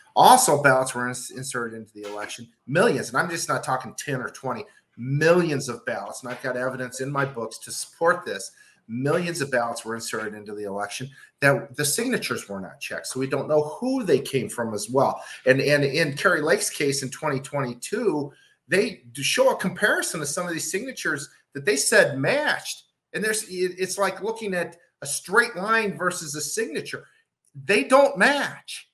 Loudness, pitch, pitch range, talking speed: -24 LUFS, 140 Hz, 125-185 Hz, 185 wpm